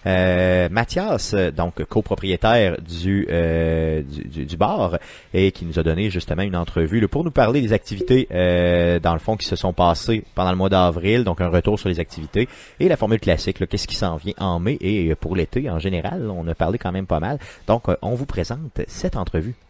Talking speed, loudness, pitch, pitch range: 215 wpm, -21 LUFS, 90 Hz, 85-105 Hz